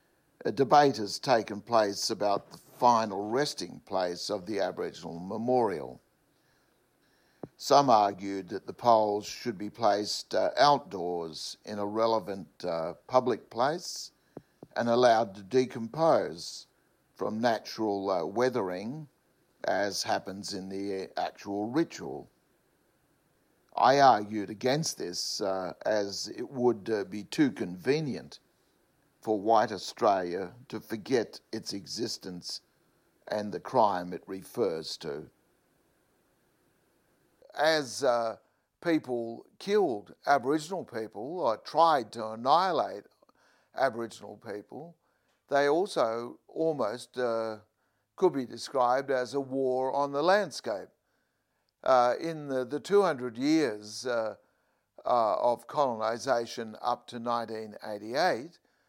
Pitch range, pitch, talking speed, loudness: 105-135 Hz, 115 Hz, 110 wpm, -29 LUFS